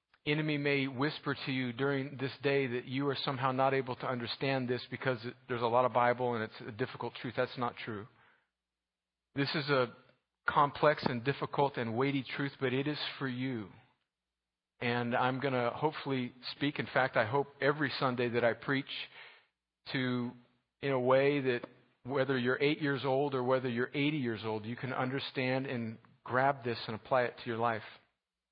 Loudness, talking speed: -34 LUFS, 185 wpm